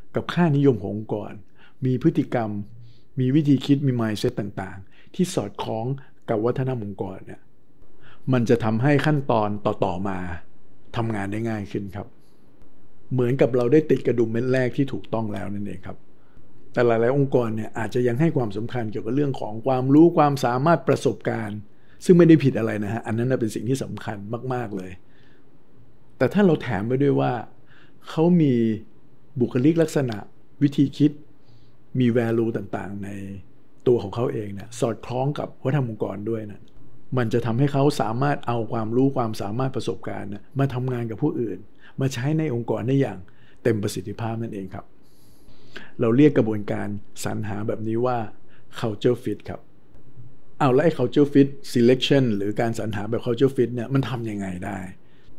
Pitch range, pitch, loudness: 110-135 Hz, 120 Hz, -23 LUFS